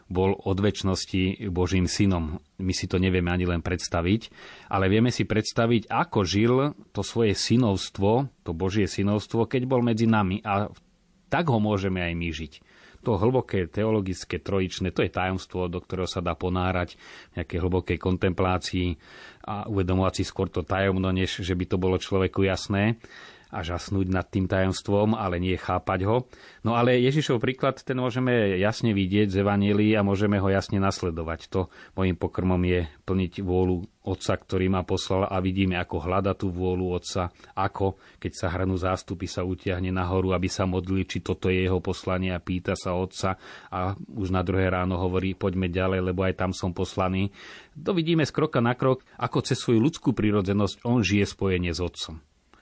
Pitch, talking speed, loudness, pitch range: 95 Hz, 175 wpm, -26 LUFS, 90-105 Hz